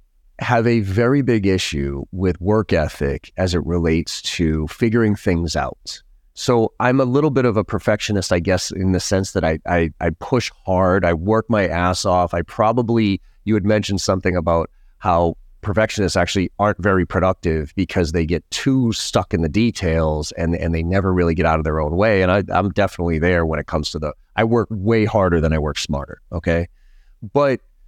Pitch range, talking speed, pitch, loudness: 85-105 Hz, 195 wpm, 95 Hz, -19 LUFS